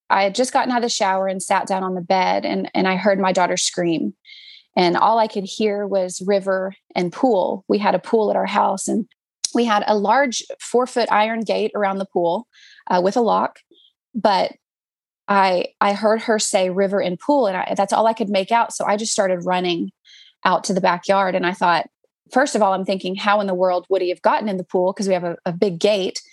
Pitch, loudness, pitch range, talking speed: 200 Hz, -19 LUFS, 185-225 Hz, 240 wpm